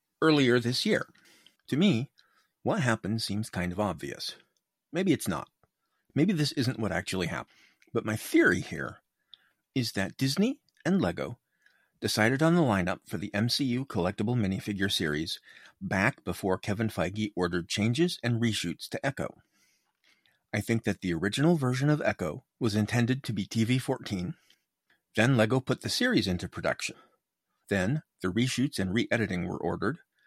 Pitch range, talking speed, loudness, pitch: 95-130 Hz, 155 wpm, -29 LUFS, 110 Hz